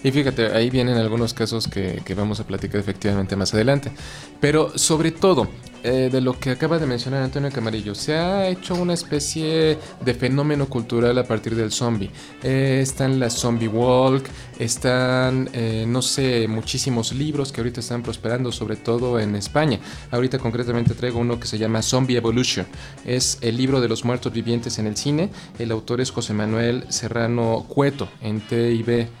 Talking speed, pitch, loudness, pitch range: 175 wpm, 120 Hz, -22 LUFS, 115-135 Hz